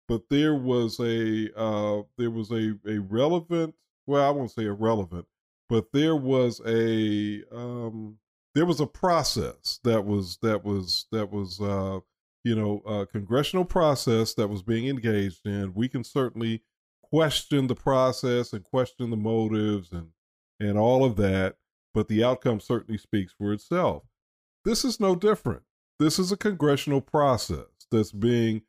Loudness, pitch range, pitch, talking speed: -26 LUFS, 105-135 Hz, 115 Hz, 155 wpm